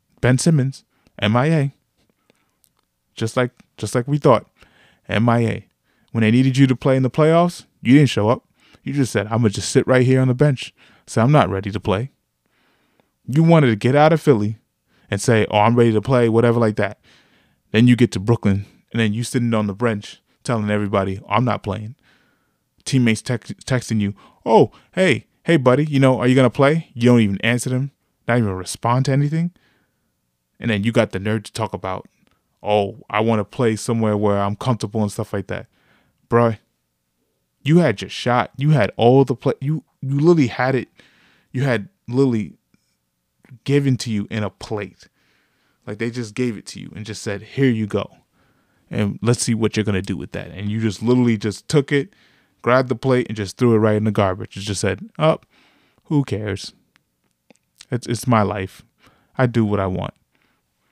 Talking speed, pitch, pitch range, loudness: 200 wpm, 115 Hz, 105-130 Hz, -19 LUFS